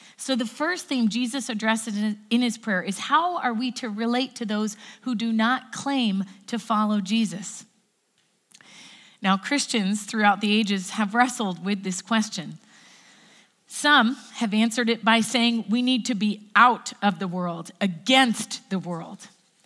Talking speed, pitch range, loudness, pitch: 155 wpm, 205-245 Hz, -24 LUFS, 220 Hz